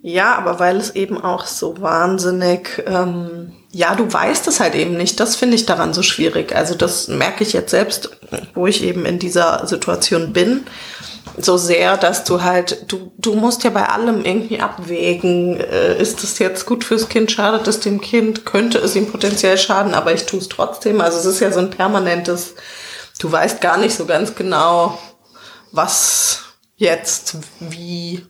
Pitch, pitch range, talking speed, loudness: 190 Hz, 175-220 Hz, 180 wpm, -16 LUFS